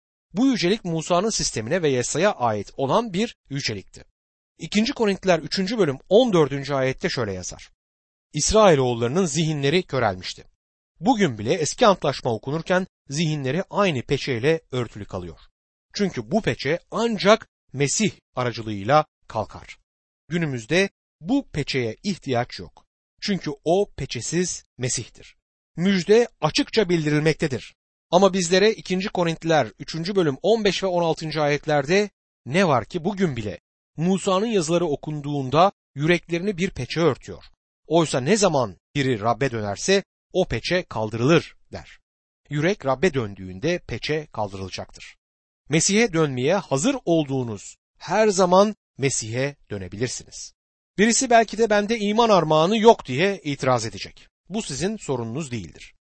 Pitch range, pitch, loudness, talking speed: 125-190 Hz, 155 Hz, -22 LUFS, 120 wpm